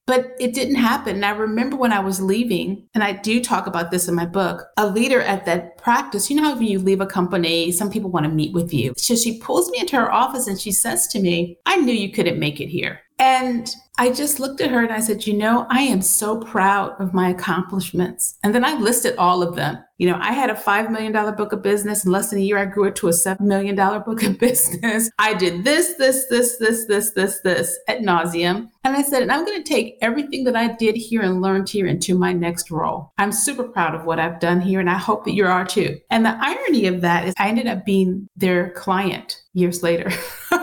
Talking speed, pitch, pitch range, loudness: 250 wpm, 205 Hz, 180-235 Hz, -19 LUFS